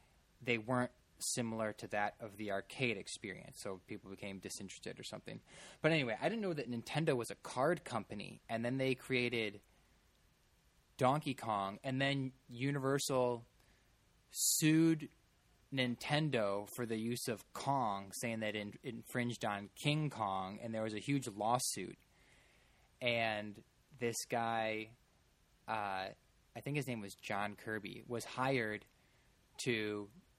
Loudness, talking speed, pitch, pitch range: -39 LUFS, 135 wpm, 115 Hz, 105-130 Hz